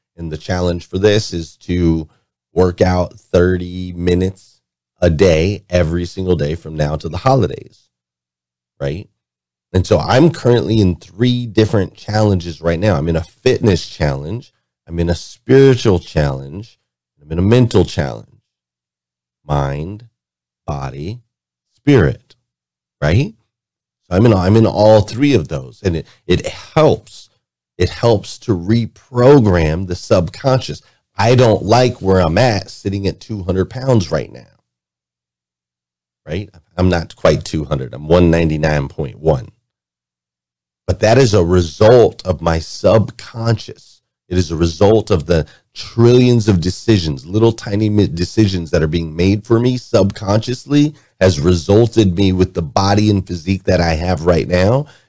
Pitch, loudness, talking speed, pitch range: 90 Hz, -15 LUFS, 140 wpm, 80-110 Hz